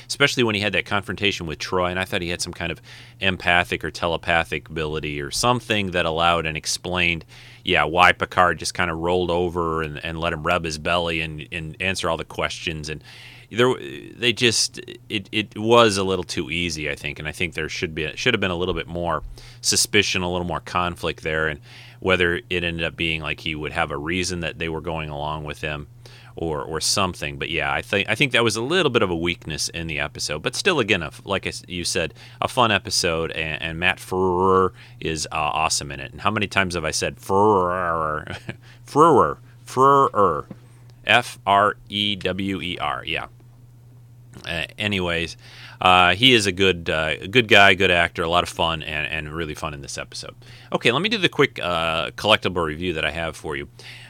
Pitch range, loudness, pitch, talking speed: 80-115 Hz, -21 LUFS, 90 Hz, 215 wpm